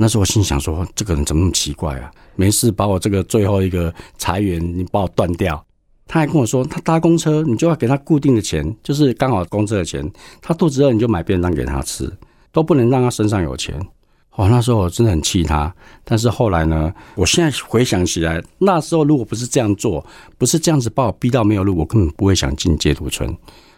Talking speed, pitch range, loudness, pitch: 345 characters per minute, 85-130 Hz, -17 LUFS, 105 Hz